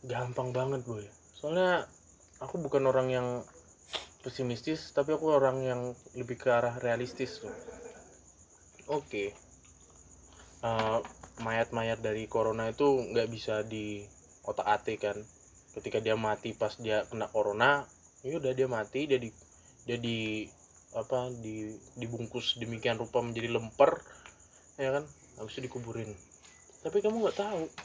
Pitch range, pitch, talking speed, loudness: 105-130 Hz, 115 Hz, 125 wpm, -33 LUFS